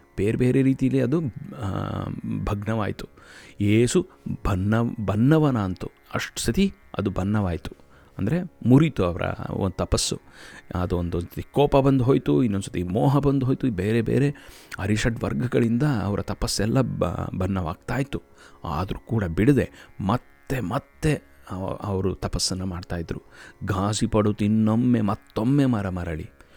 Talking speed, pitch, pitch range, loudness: 115 wpm, 105 Hz, 95-130 Hz, -24 LUFS